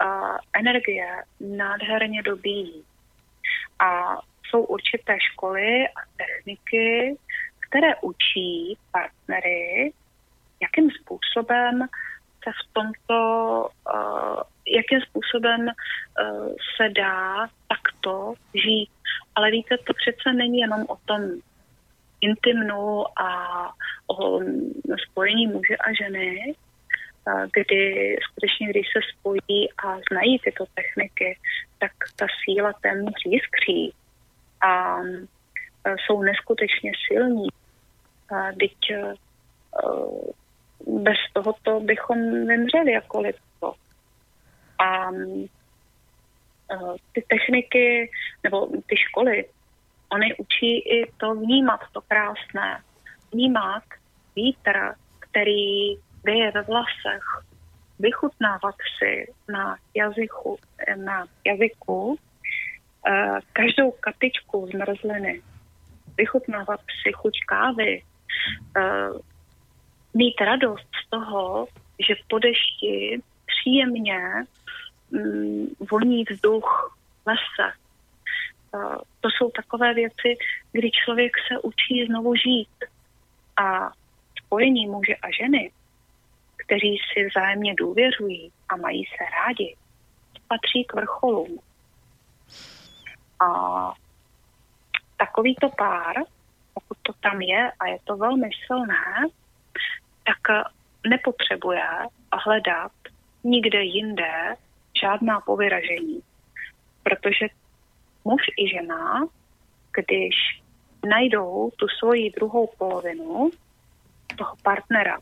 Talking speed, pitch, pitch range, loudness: 90 wpm, 220 Hz, 195-250 Hz, -23 LUFS